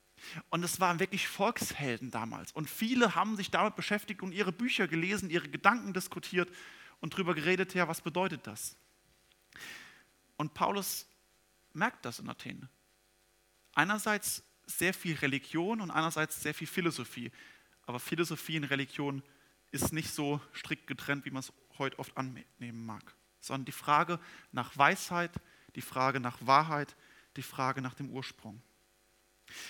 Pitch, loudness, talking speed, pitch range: 155 Hz, -34 LUFS, 145 wpm, 130-185 Hz